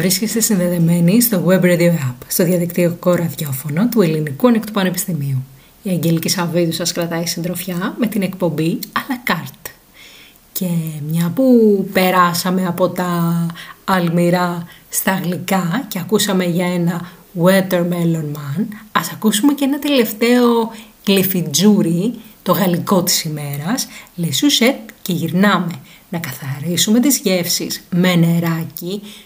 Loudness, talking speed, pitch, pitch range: -16 LUFS, 120 wpm, 180 Hz, 170-210 Hz